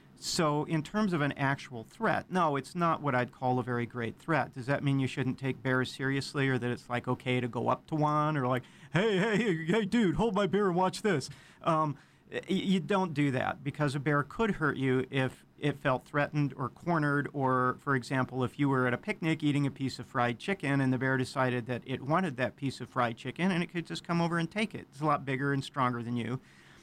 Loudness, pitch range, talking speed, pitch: -31 LUFS, 125-160 Hz, 240 wpm, 140 Hz